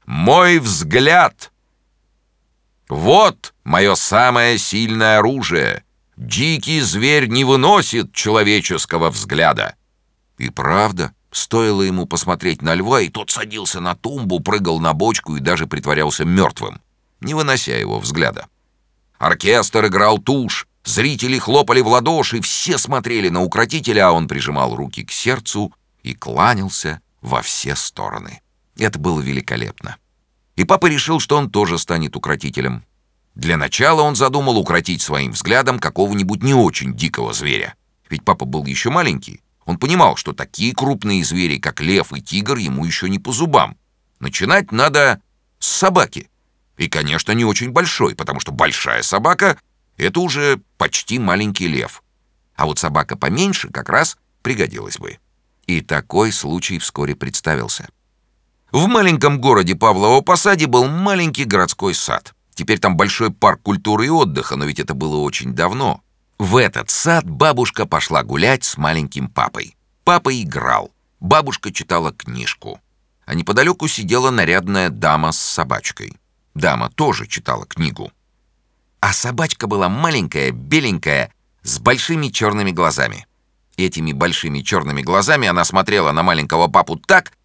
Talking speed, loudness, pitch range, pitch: 135 wpm, -16 LUFS, 80-135 Hz, 105 Hz